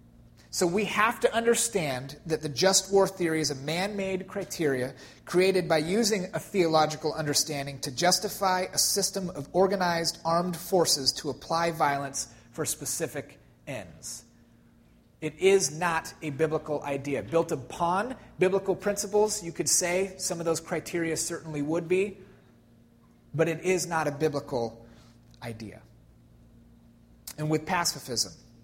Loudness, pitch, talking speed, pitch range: -27 LUFS, 165 Hz, 135 wpm, 145-185 Hz